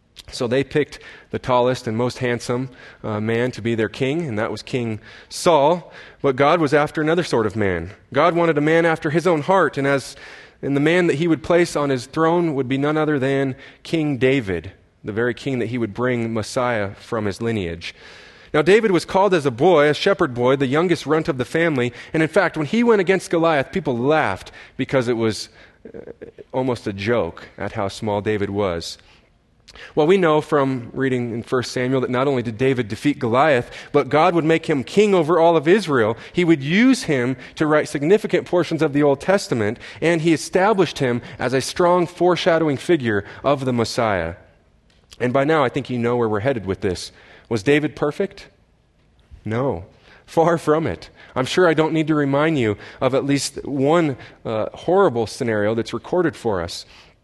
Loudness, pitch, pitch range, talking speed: -20 LUFS, 135 Hz, 115-160 Hz, 200 wpm